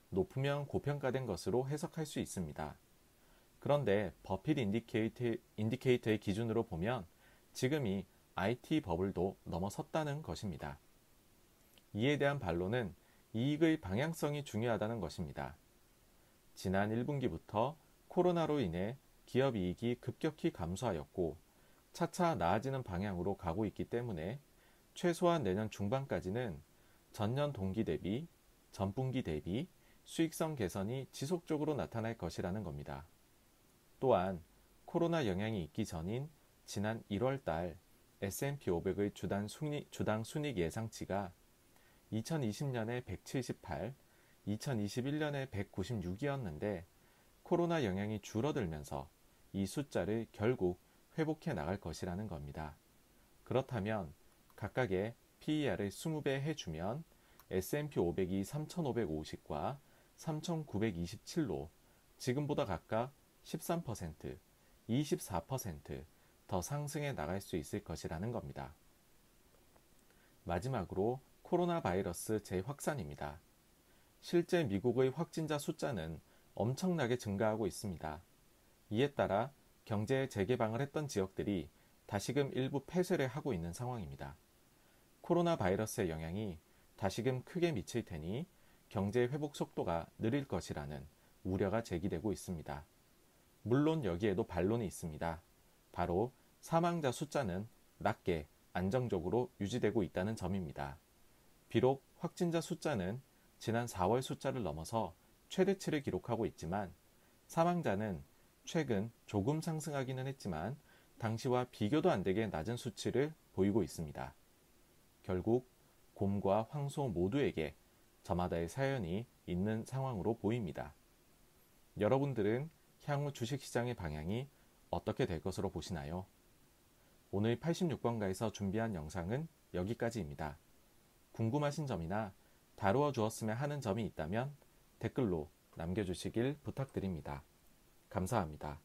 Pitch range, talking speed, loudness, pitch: 95-140 Hz, 260 characters per minute, -39 LUFS, 115 Hz